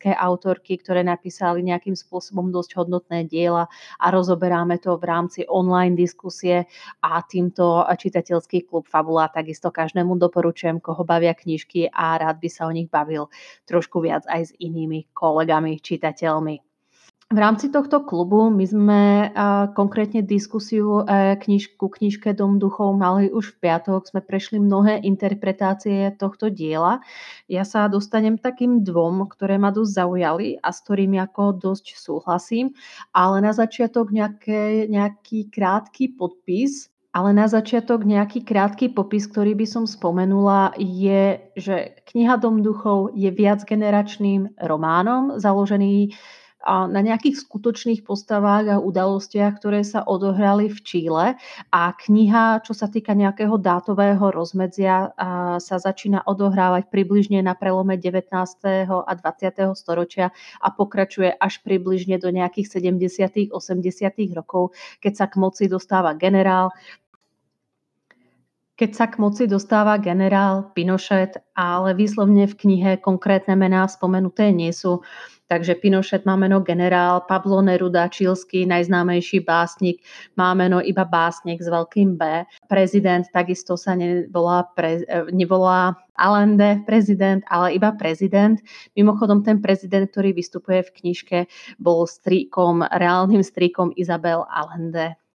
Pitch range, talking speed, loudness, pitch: 175-205 Hz, 130 wpm, -20 LUFS, 190 Hz